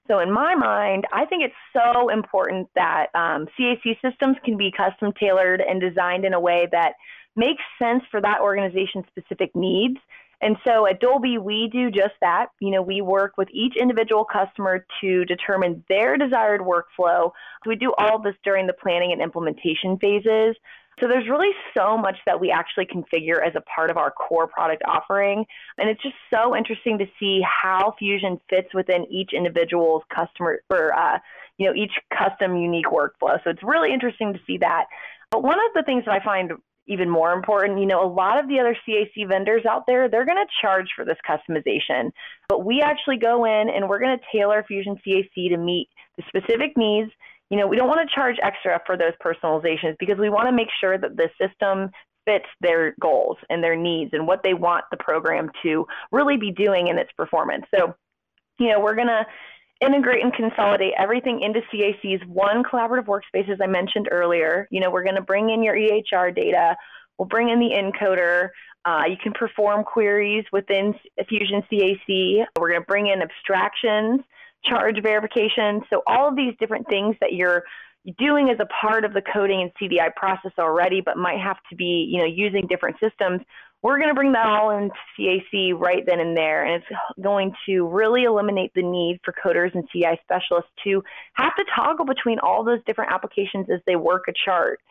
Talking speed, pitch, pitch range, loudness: 195 wpm, 200 Hz, 185-225 Hz, -21 LUFS